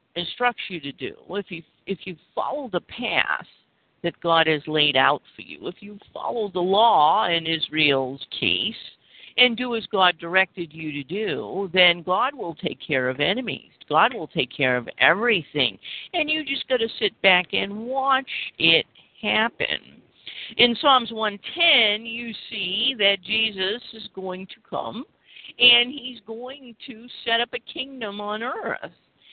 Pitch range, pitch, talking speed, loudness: 170-240 Hz, 205 Hz, 160 wpm, -22 LUFS